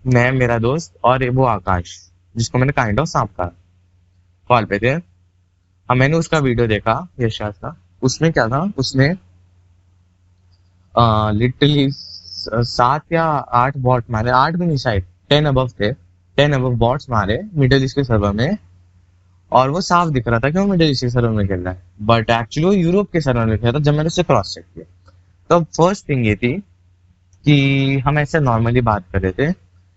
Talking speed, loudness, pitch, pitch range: 175 wpm, -17 LUFS, 120 Hz, 90-140 Hz